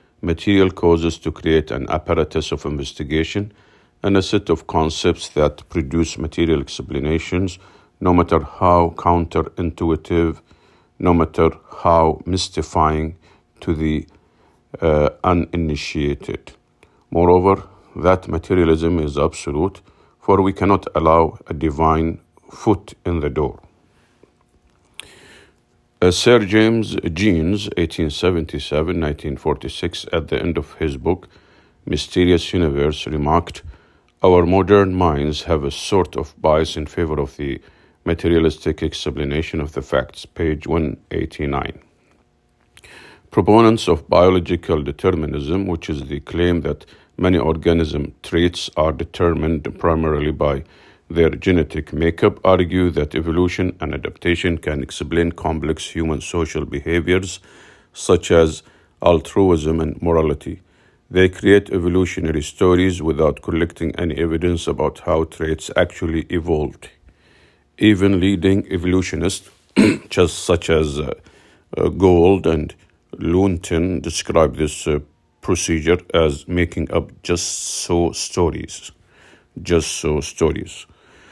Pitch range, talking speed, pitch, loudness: 80-90 Hz, 110 wpm, 85 Hz, -18 LUFS